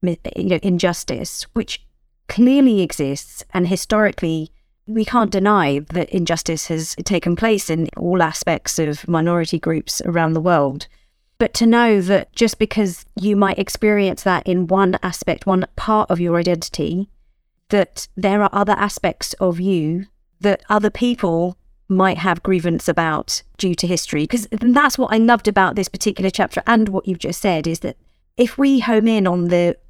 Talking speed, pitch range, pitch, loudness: 165 wpm, 170-210 Hz, 190 Hz, -18 LUFS